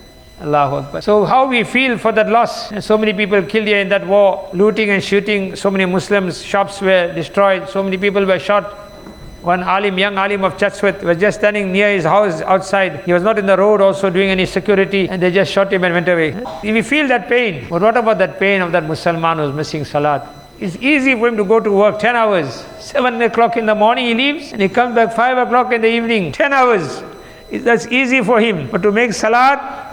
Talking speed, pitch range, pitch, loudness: 230 wpm, 190-230 Hz, 205 Hz, -14 LUFS